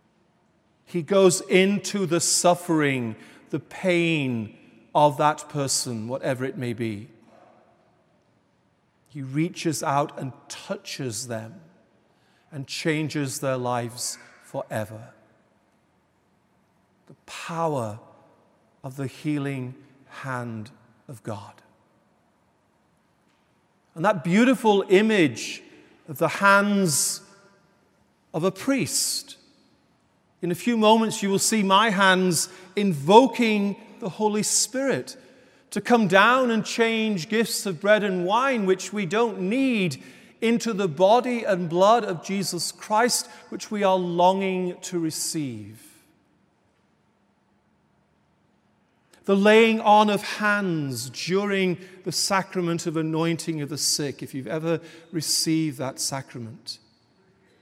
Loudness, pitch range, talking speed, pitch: -23 LUFS, 140-200 Hz, 105 wpm, 175 Hz